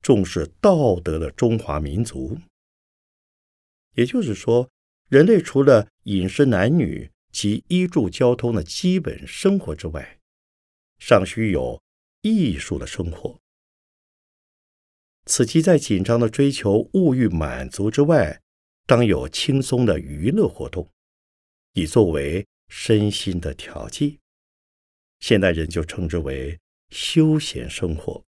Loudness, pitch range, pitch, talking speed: -20 LUFS, 80-135 Hz, 105 Hz, 175 characters per minute